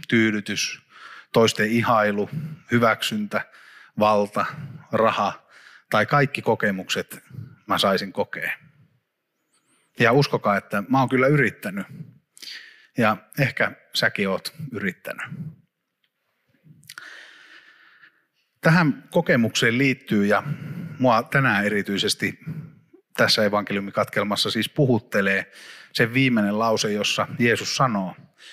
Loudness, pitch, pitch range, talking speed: -22 LUFS, 115 Hz, 105-135 Hz, 85 wpm